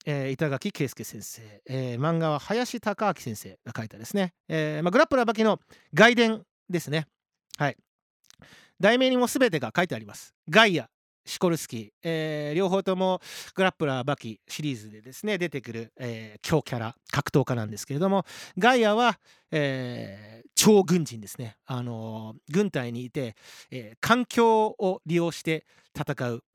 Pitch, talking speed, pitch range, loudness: 155 Hz, 320 characters per minute, 120-195 Hz, -26 LUFS